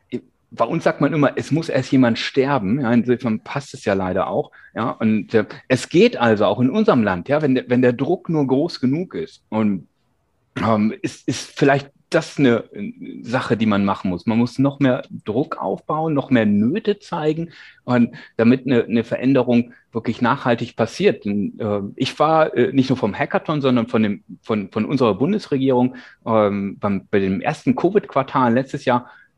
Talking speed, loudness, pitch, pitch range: 180 wpm, -19 LUFS, 125 Hz, 110-145 Hz